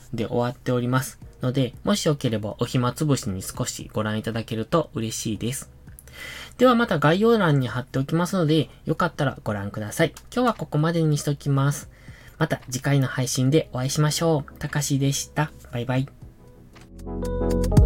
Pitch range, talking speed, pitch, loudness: 120-155 Hz, 355 characters per minute, 135 Hz, -24 LUFS